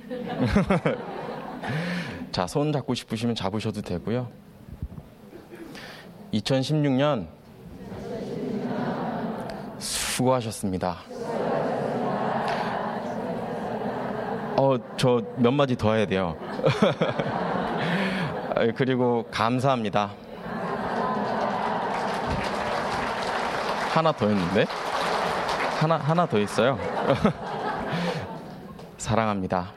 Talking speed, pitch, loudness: 120 characters per minute, 135 Hz, -26 LUFS